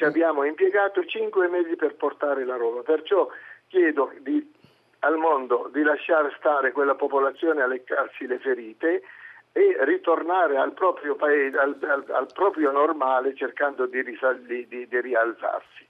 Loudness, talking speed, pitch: -24 LUFS, 150 wpm, 150 Hz